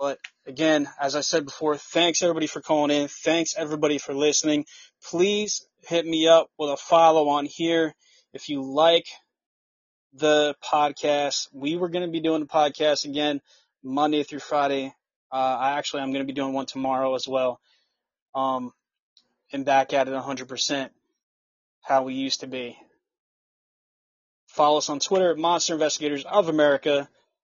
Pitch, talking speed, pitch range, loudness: 145 Hz, 160 wpm, 135-160 Hz, -24 LUFS